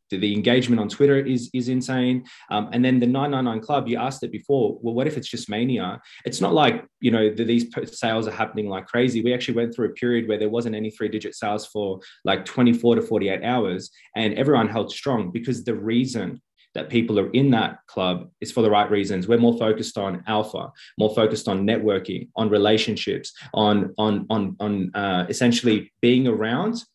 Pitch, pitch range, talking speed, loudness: 115 Hz, 105-120 Hz, 205 wpm, -22 LUFS